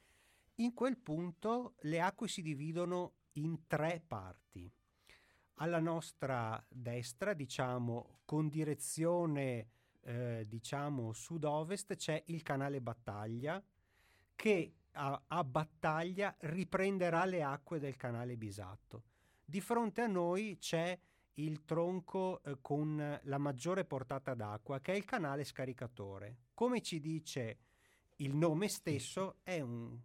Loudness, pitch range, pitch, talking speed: -40 LUFS, 120-175 Hz, 150 Hz, 120 wpm